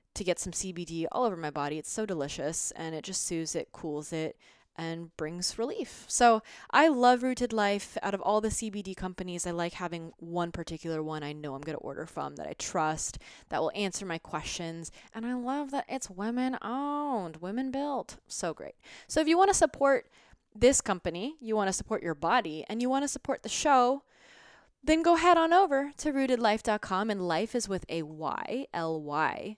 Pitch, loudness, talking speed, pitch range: 200 Hz, -30 LUFS, 205 wpm, 165-255 Hz